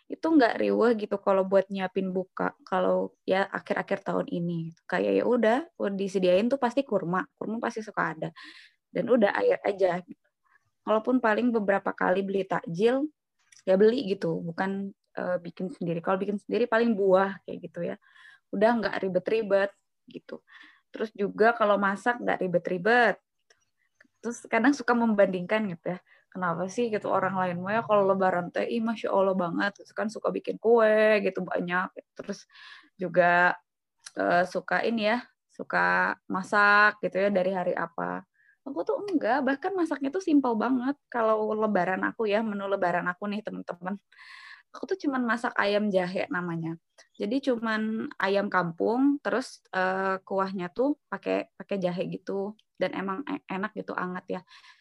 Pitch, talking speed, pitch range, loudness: 200 Hz, 155 wpm, 185-235 Hz, -27 LUFS